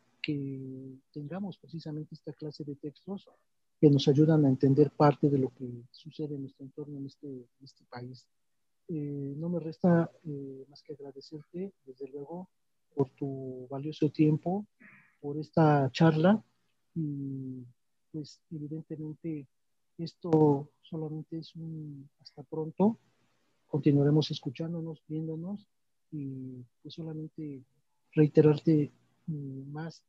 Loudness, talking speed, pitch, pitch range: -30 LUFS, 120 wpm, 150 Hz, 135-160 Hz